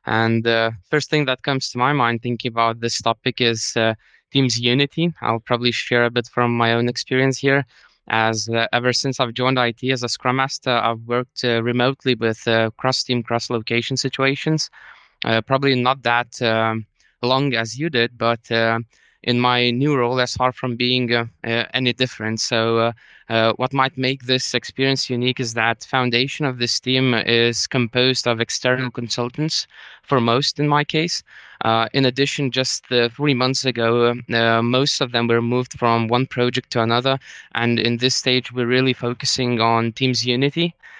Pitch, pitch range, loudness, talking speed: 125 Hz, 115-130 Hz, -19 LUFS, 185 wpm